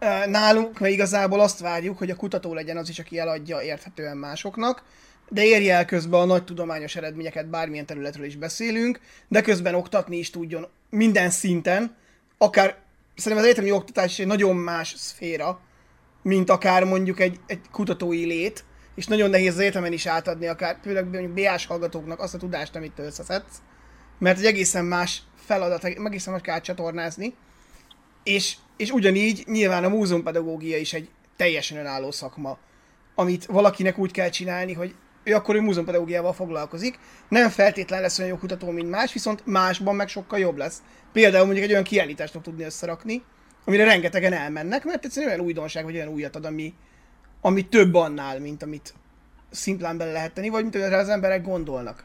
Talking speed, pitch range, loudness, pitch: 170 wpm, 165-200 Hz, -23 LUFS, 185 Hz